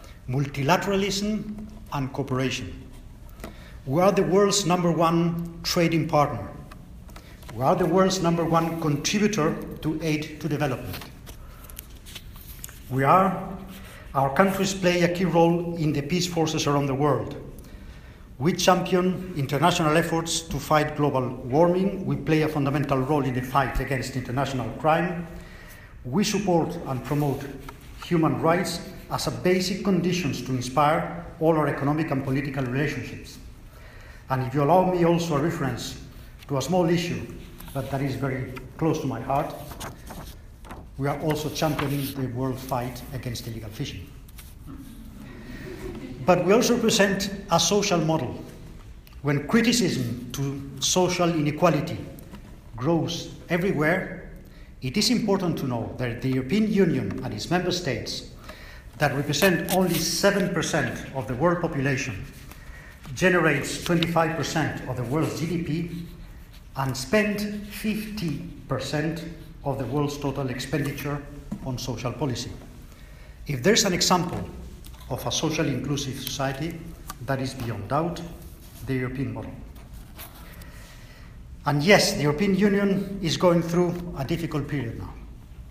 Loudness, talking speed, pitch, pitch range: -25 LUFS, 130 wpm, 150 Hz, 130-175 Hz